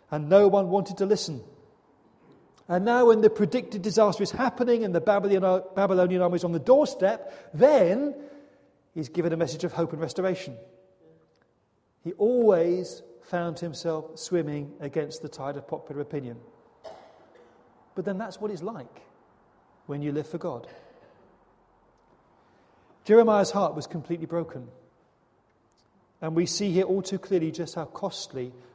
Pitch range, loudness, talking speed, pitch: 150-200 Hz, -25 LUFS, 140 wpm, 175 Hz